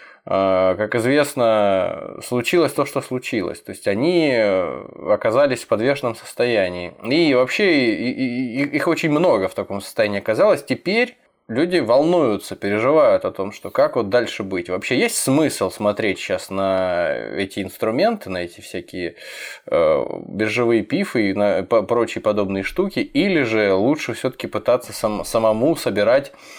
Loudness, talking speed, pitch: -19 LUFS, 130 wpm, 120 Hz